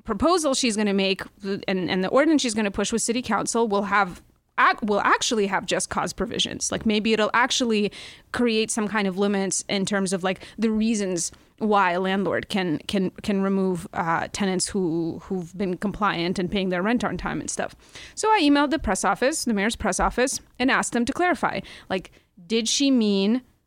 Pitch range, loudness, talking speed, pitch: 195-230 Hz, -23 LUFS, 200 wpm, 205 Hz